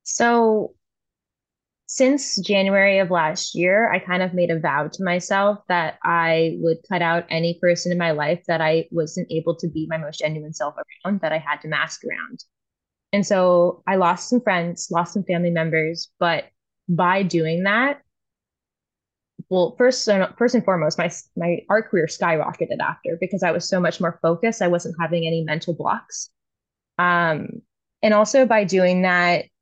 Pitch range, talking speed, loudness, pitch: 165-195 Hz, 170 wpm, -20 LUFS, 175 Hz